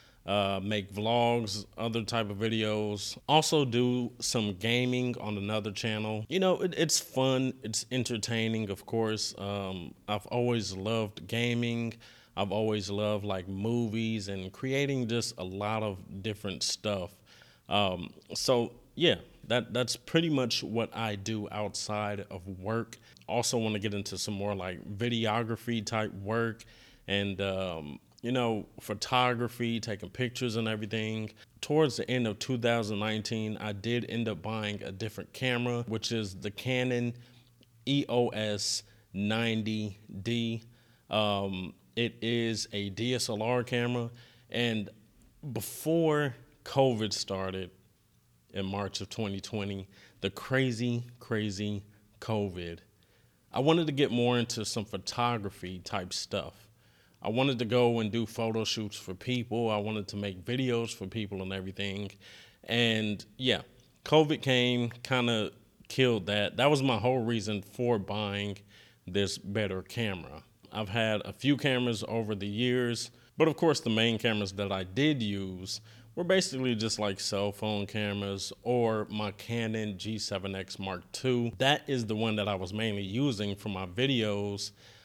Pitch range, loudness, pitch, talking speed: 100-120 Hz, -31 LUFS, 110 Hz, 140 wpm